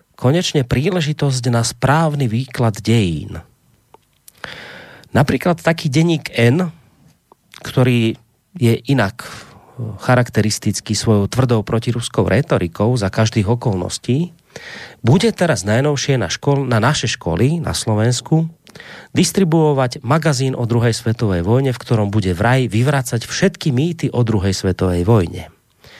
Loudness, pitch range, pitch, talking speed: -17 LUFS, 110-145 Hz, 125 Hz, 110 wpm